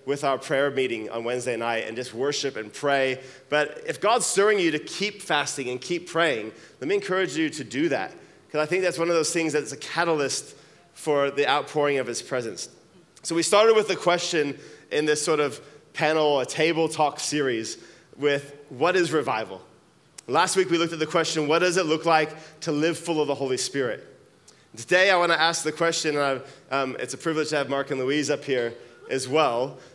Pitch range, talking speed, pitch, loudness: 135-165 Hz, 210 wpm, 150 Hz, -24 LUFS